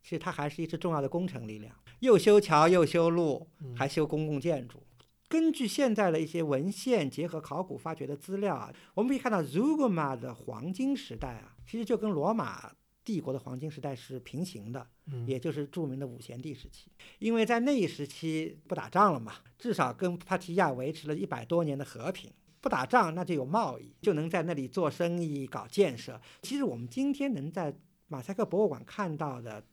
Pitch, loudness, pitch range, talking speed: 165 Hz, -31 LUFS, 140-195 Hz, 305 characters per minute